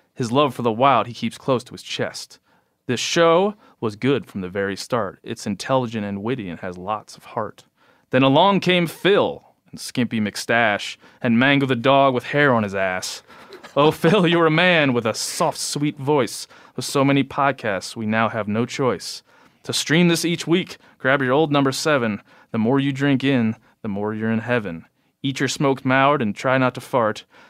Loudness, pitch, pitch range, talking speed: -20 LUFS, 135 Hz, 115-145 Hz, 200 wpm